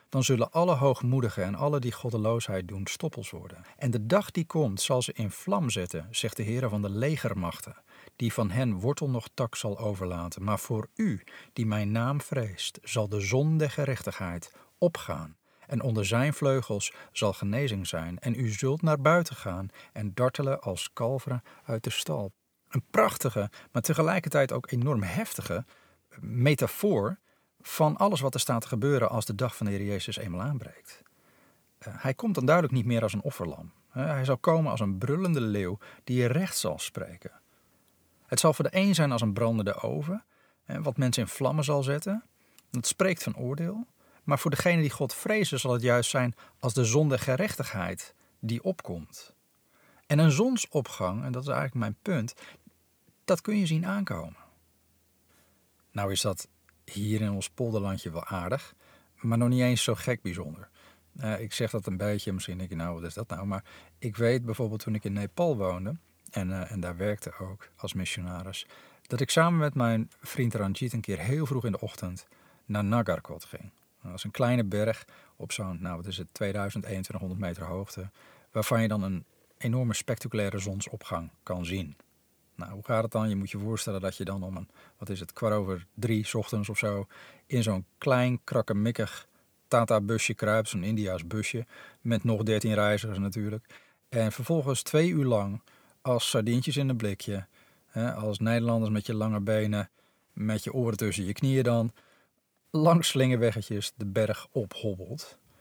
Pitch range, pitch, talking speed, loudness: 100-130 Hz, 115 Hz, 180 wpm, -29 LUFS